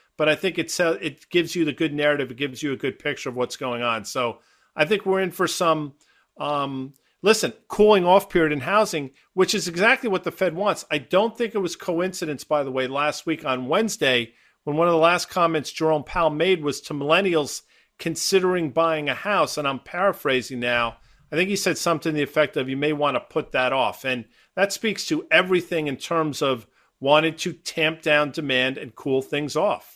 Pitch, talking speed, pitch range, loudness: 155 Hz, 210 wpm, 145-180 Hz, -23 LUFS